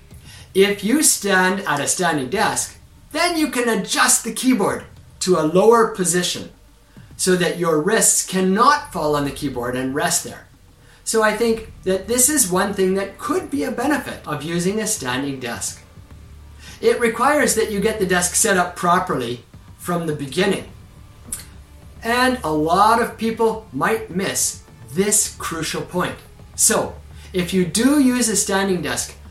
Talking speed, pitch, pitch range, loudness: 160 wpm, 185 Hz, 150-225 Hz, -18 LUFS